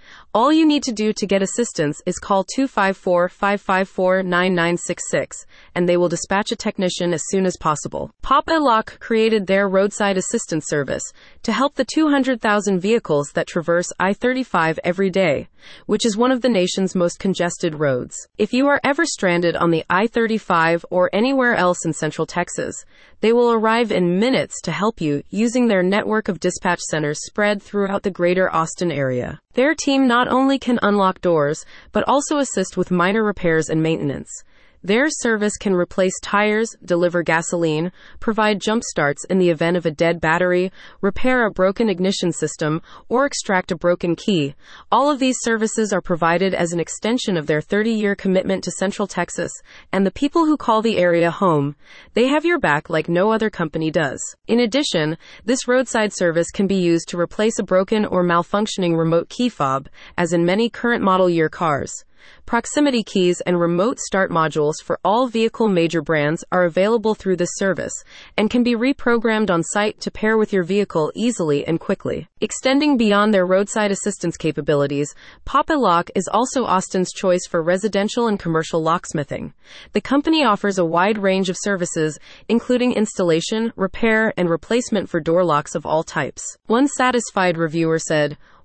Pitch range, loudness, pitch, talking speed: 170-225 Hz, -19 LUFS, 190 Hz, 170 wpm